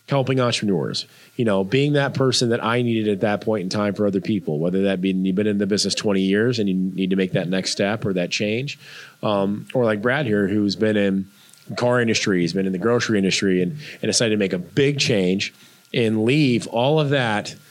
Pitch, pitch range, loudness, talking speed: 105 Hz, 95-120 Hz, -21 LUFS, 230 wpm